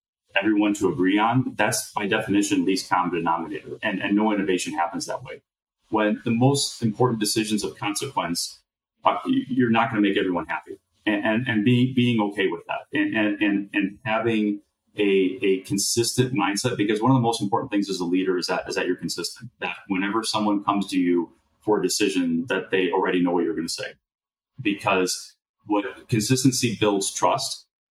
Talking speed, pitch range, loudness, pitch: 190 wpm, 100-120 Hz, -23 LUFS, 105 Hz